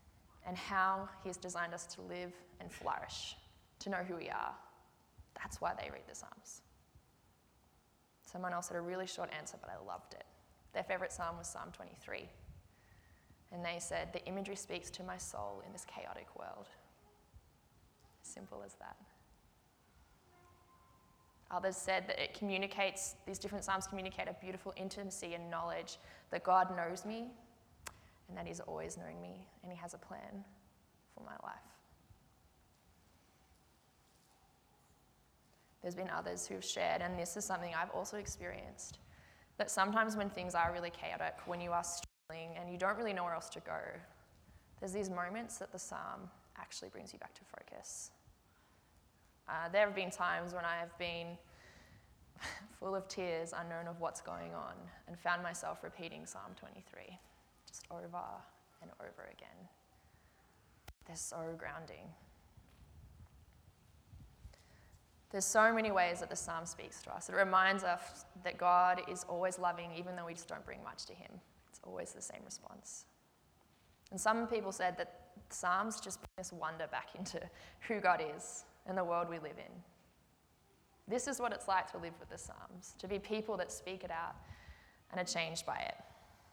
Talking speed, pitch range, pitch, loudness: 165 wpm, 130-190 Hz, 175 Hz, -40 LUFS